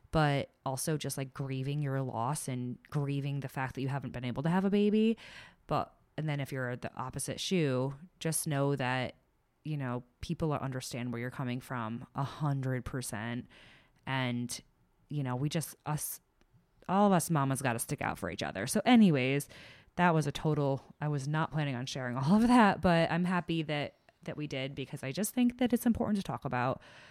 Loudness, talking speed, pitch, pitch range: -33 LUFS, 200 wpm, 140 Hz, 130-160 Hz